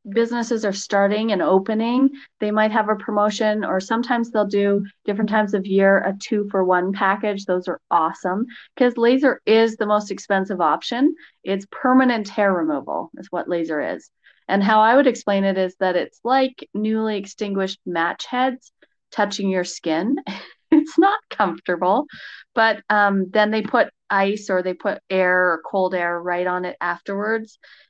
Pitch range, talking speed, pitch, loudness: 190-230 Hz, 170 wpm, 210 Hz, -20 LUFS